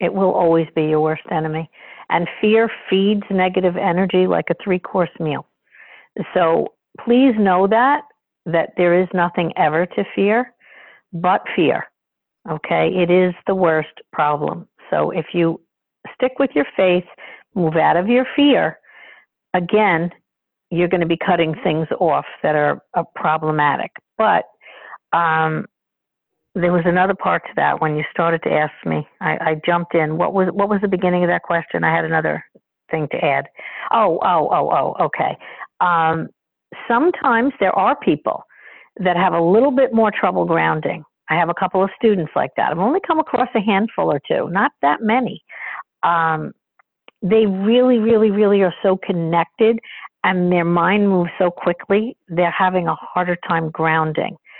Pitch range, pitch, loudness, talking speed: 165-210 Hz, 180 Hz, -18 LUFS, 165 wpm